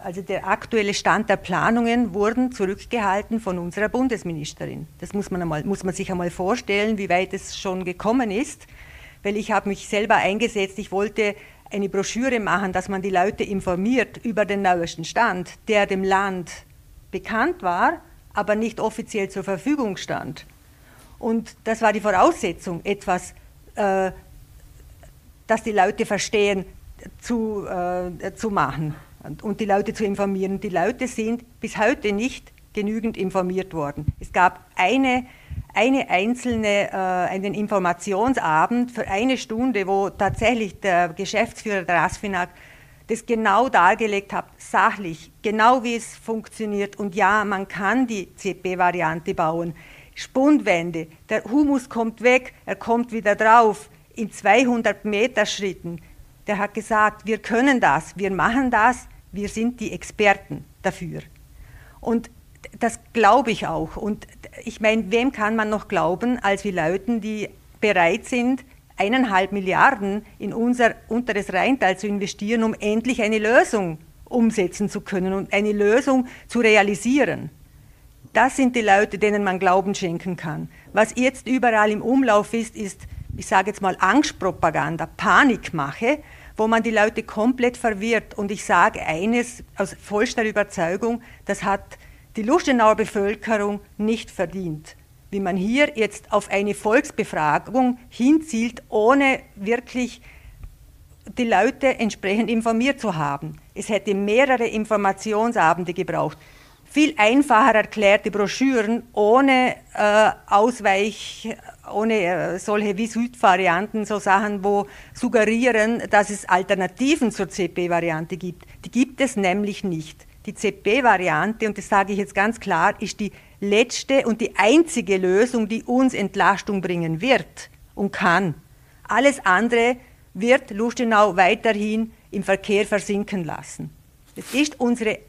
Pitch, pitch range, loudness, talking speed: 210 Hz, 190-230 Hz, -21 LUFS, 135 wpm